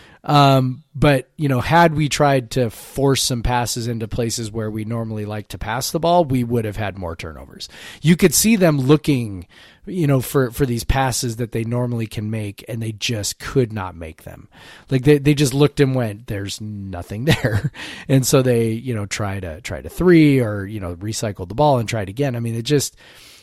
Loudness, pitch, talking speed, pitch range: -19 LUFS, 120 Hz, 215 wpm, 105-140 Hz